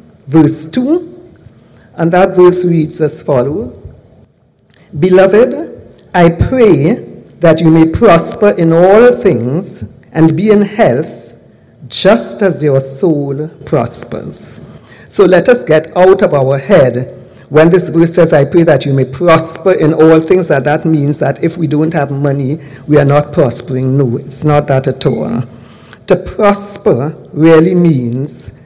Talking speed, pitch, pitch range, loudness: 150 wpm, 160 Hz, 145-180 Hz, -10 LUFS